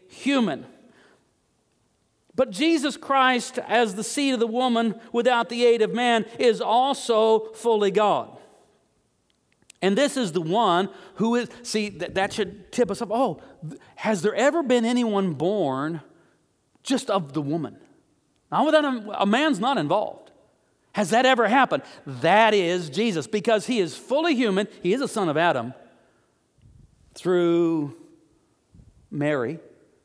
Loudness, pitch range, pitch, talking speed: -23 LUFS, 195-250 Hz, 225 Hz, 140 wpm